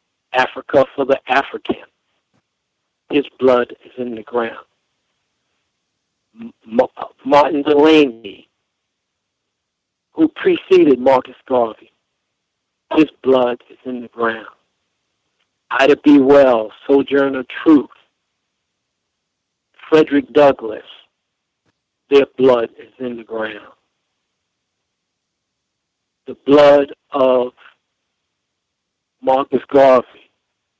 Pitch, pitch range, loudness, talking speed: 135 Hz, 125-145 Hz, -15 LUFS, 80 wpm